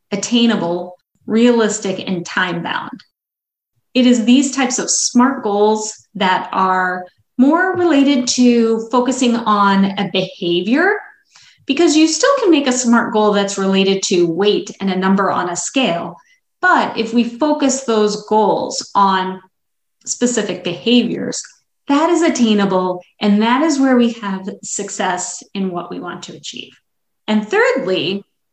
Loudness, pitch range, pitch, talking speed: -15 LUFS, 190-255 Hz, 215 Hz, 140 wpm